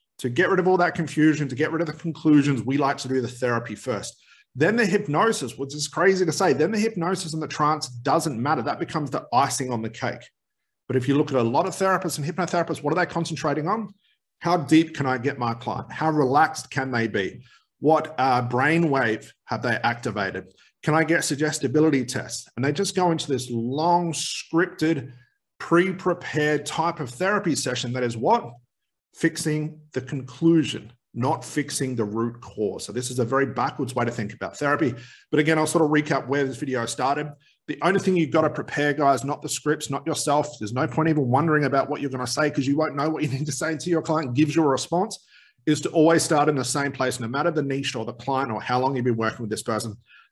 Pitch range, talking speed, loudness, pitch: 130-160 Hz, 230 wpm, -24 LUFS, 145 Hz